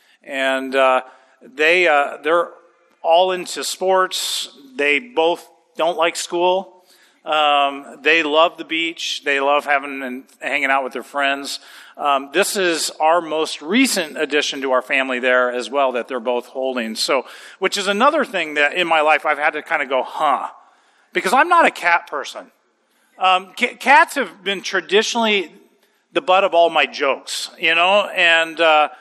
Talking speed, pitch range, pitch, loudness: 170 wpm, 140-180 Hz, 160 Hz, -17 LUFS